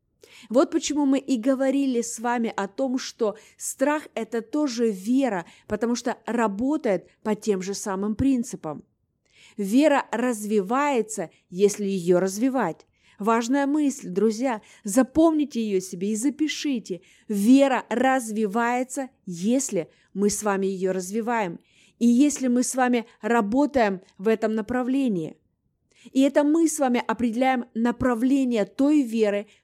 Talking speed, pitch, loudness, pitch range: 125 wpm, 235 Hz, -24 LUFS, 205-265 Hz